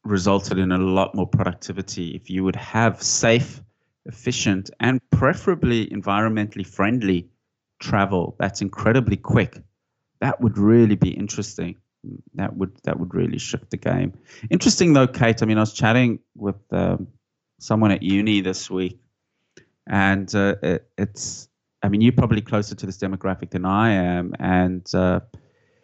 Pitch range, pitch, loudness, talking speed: 95-115 Hz, 100 Hz, -21 LUFS, 150 wpm